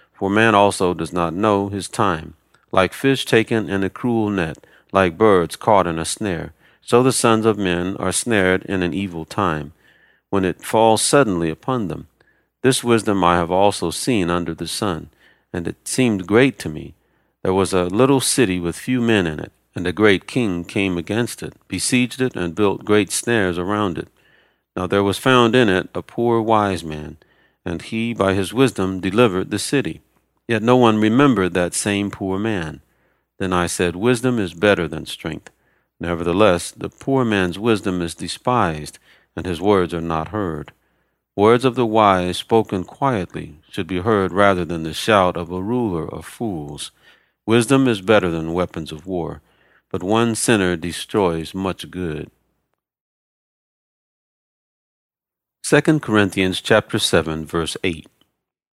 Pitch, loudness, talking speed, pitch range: 100 Hz, -19 LUFS, 165 wpm, 85-115 Hz